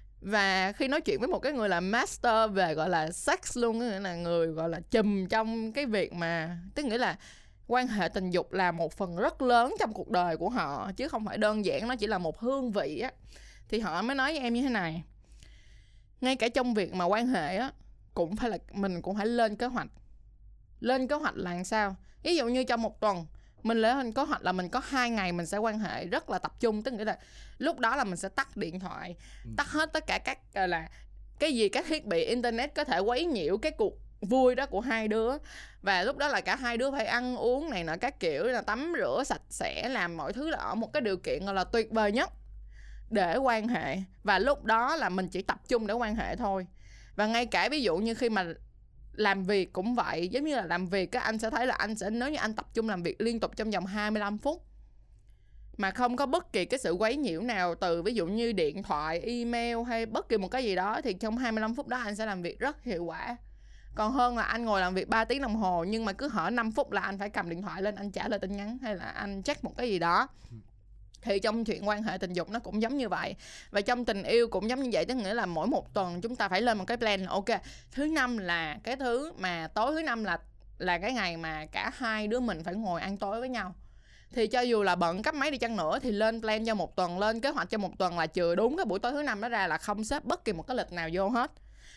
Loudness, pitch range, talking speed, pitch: -31 LUFS, 190-245 Hz, 265 wpm, 220 Hz